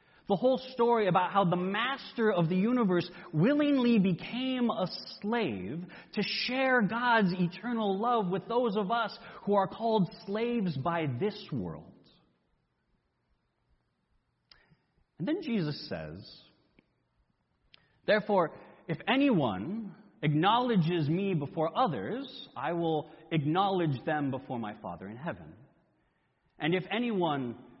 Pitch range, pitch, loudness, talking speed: 165-230 Hz, 195 Hz, -30 LUFS, 115 wpm